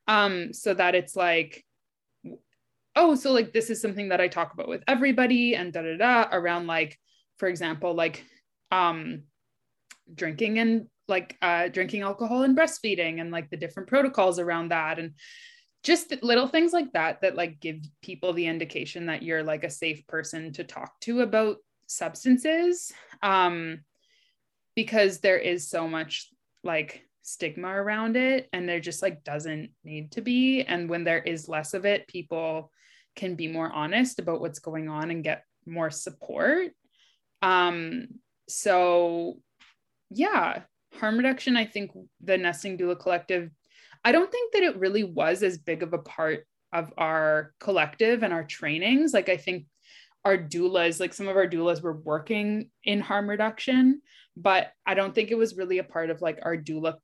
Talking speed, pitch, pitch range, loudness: 170 wpm, 180 Hz, 165-225 Hz, -26 LUFS